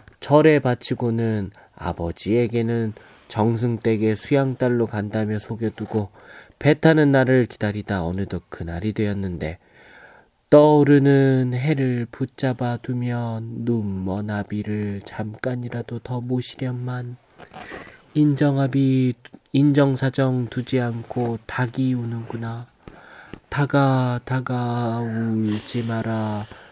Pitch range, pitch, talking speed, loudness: 110-130 Hz, 120 Hz, 220 characters per minute, -22 LUFS